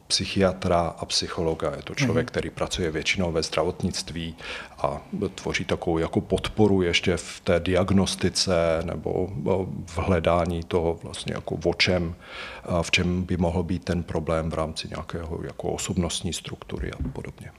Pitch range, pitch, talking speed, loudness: 85-95 Hz, 90 Hz, 145 wpm, -26 LUFS